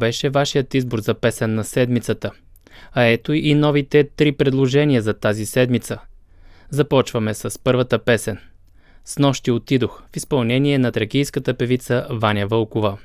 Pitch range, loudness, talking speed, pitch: 110-135 Hz, -19 LUFS, 140 wpm, 120 Hz